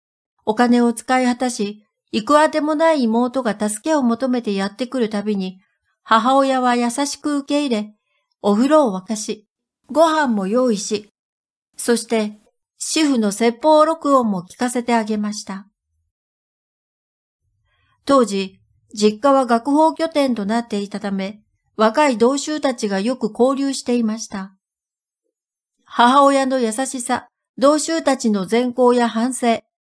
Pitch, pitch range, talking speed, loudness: 240 Hz, 210-275 Hz, 250 characters per minute, -18 LUFS